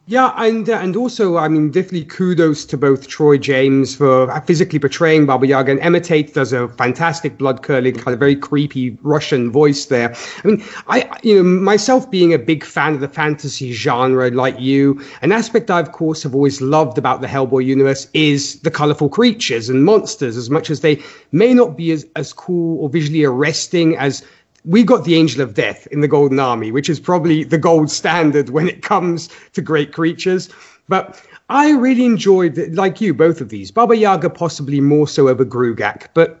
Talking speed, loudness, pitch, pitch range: 195 wpm, -15 LUFS, 155 Hz, 140-175 Hz